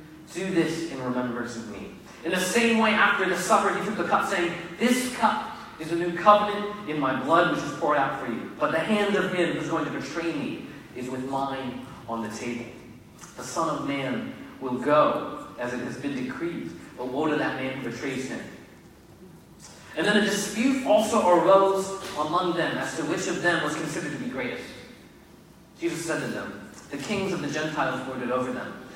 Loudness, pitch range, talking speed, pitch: -26 LUFS, 130-200 Hz, 205 wpm, 170 Hz